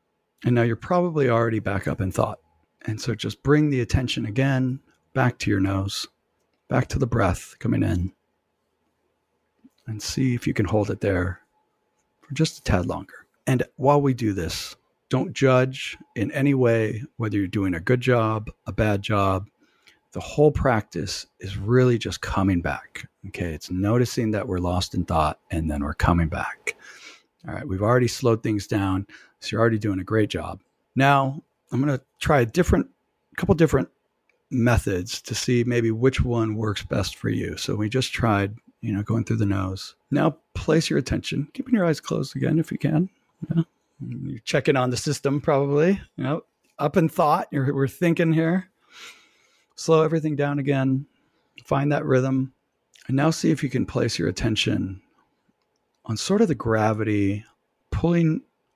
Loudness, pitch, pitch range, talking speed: -24 LUFS, 120 Hz, 100-140 Hz, 175 wpm